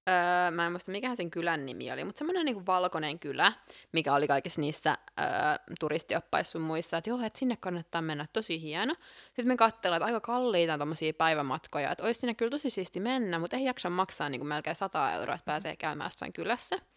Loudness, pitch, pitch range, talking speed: -31 LUFS, 180 Hz, 160-235 Hz, 210 wpm